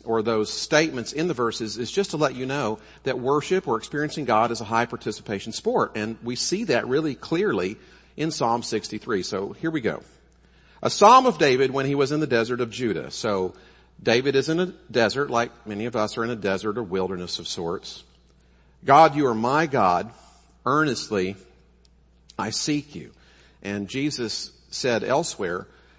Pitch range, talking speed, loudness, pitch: 95-140 Hz, 180 wpm, -24 LUFS, 115 Hz